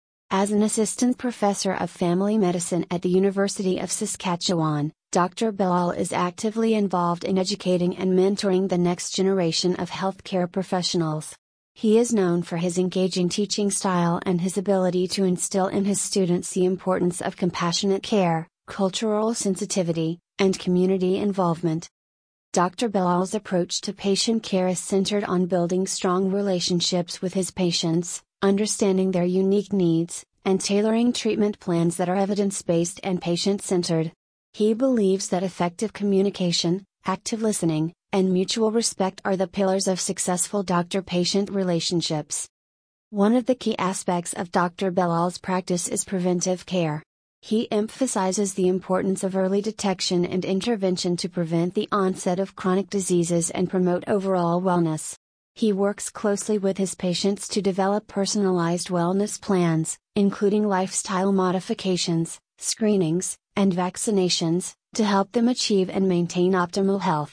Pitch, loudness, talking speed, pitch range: 185 Hz, -23 LUFS, 140 wpm, 180-200 Hz